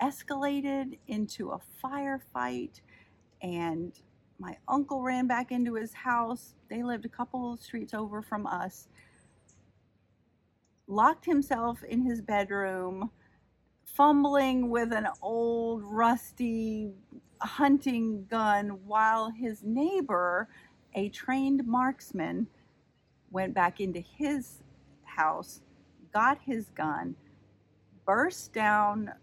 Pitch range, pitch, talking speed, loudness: 200-260 Hz, 230 Hz, 100 wpm, -30 LUFS